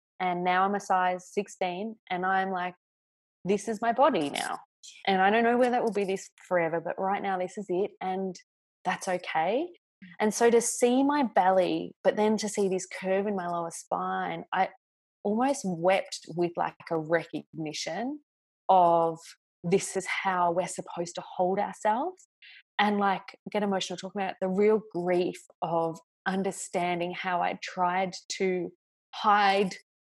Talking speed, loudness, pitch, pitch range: 160 wpm, -28 LUFS, 190 Hz, 180-205 Hz